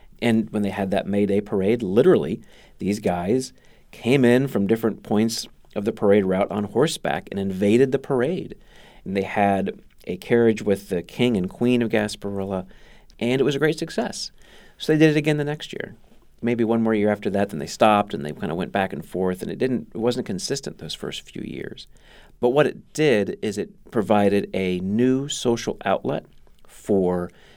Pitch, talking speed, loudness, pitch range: 110 Hz, 200 wpm, -22 LUFS, 100-125 Hz